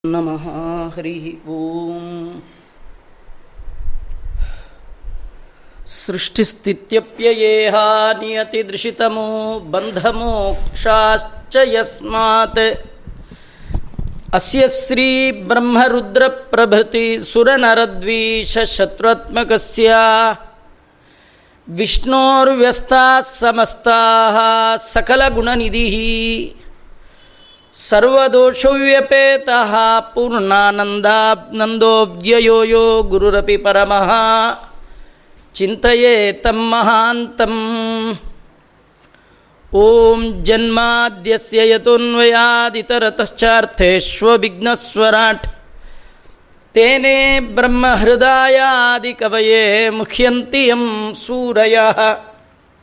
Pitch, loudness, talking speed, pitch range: 225 Hz, -12 LUFS, 35 wpm, 215-235 Hz